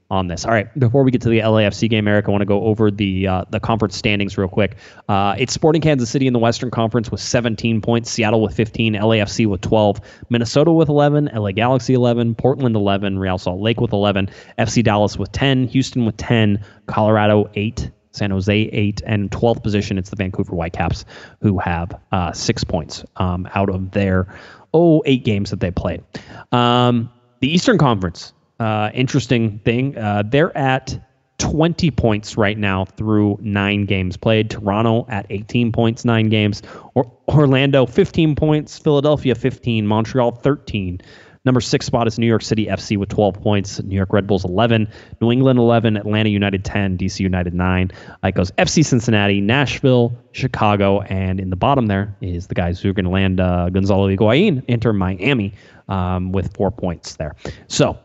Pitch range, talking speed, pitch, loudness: 100-120 Hz, 180 wpm, 110 Hz, -18 LUFS